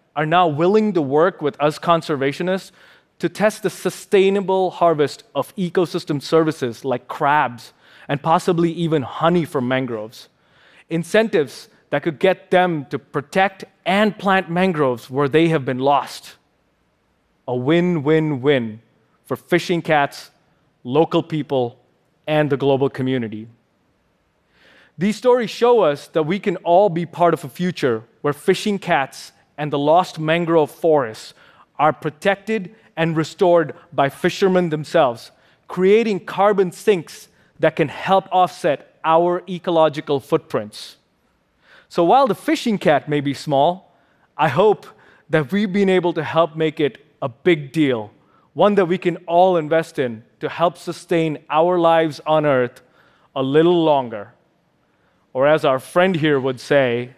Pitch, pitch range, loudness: 165 Hz, 145-180 Hz, -19 LUFS